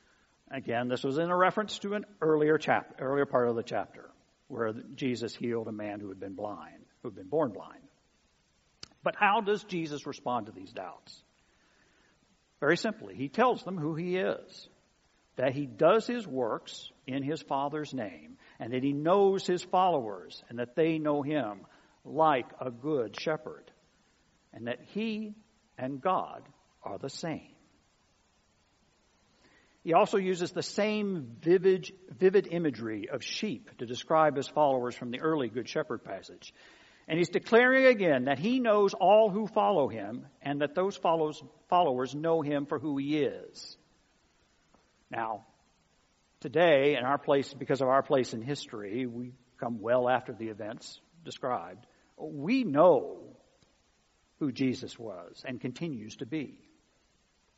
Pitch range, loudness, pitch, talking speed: 130-185 Hz, -30 LUFS, 150 Hz, 150 wpm